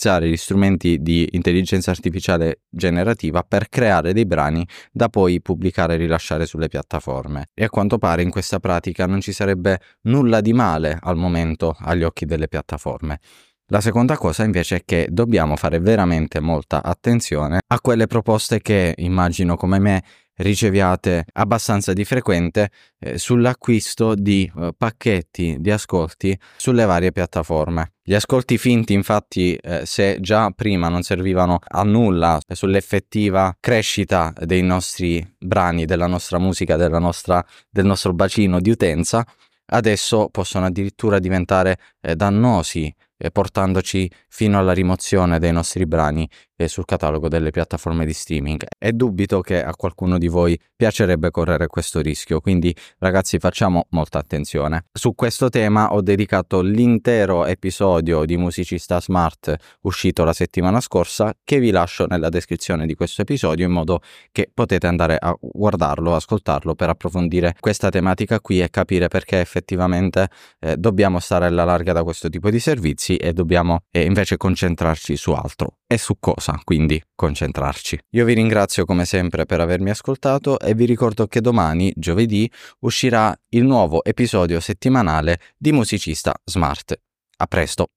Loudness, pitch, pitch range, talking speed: -19 LUFS, 90 Hz, 85-105 Hz, 145 wpm